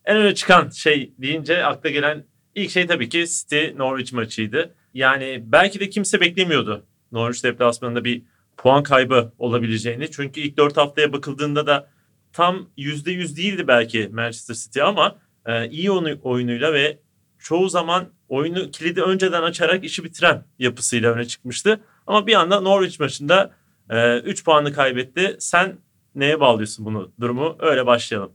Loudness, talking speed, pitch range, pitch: -19 LUFS, 145 wpm, 120-175 Hz, 145 Hz